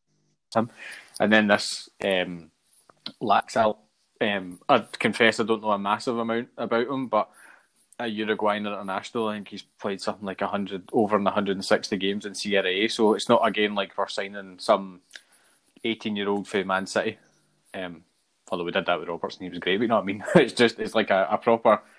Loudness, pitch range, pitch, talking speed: -25 LUFS, 95-110 Hz, 100 Hz, 195 wpm